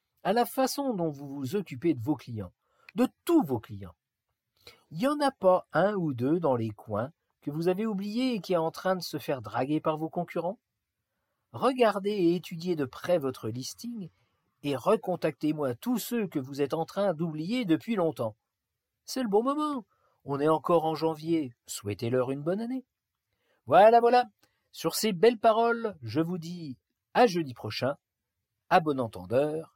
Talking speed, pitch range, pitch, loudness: 175 wpm, 135-210 Hz, 165 Hz, -28 LUFS